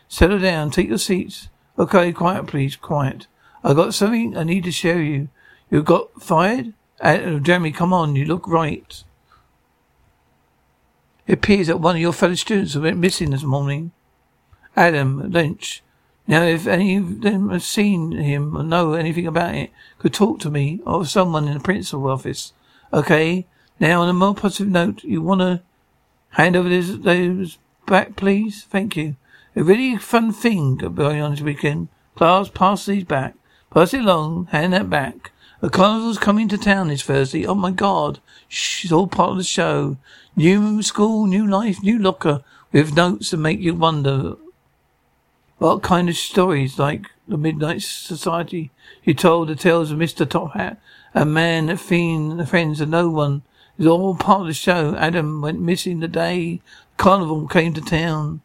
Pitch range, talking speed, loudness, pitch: 155-190 Hz, 175 wpm, -19 LUFS, 170 Hz